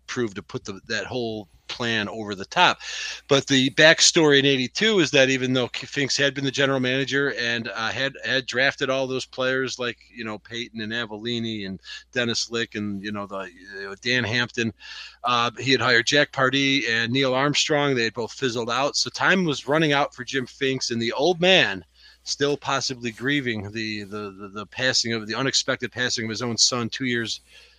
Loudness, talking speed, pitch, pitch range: -22 LUFS, 200 wpm, 125 Hz, 115-135 Hz